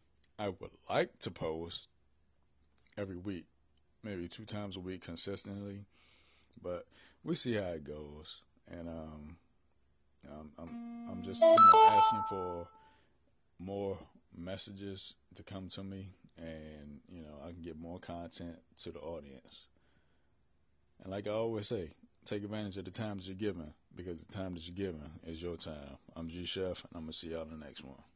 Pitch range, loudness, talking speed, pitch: 75-100 Hz, -34 LUFS, 170 wpm, 85 Hz